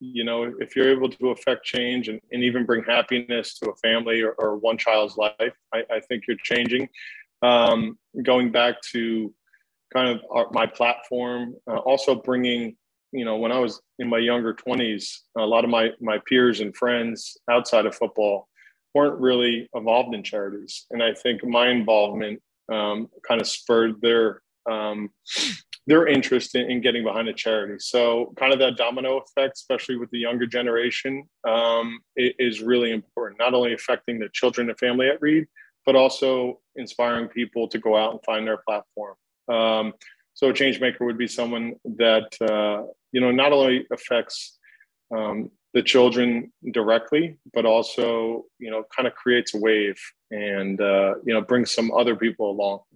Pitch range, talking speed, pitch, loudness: 115-125 Hz, 175 wpm, 120 Hz, -23 LUFS